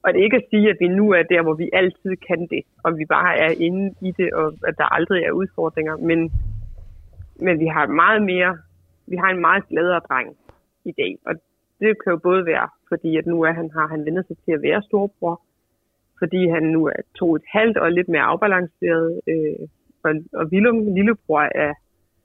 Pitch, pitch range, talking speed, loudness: 165 Hz, 155-185 Hz, 215 wpm, -19 LUFS